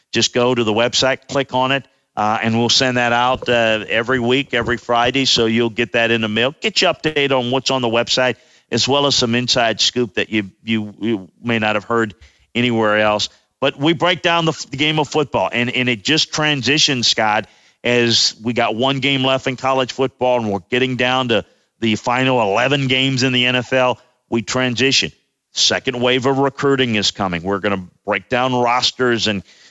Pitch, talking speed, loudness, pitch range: 125 Hz, 205 wpm, -16 LUFS, 115-130 Hz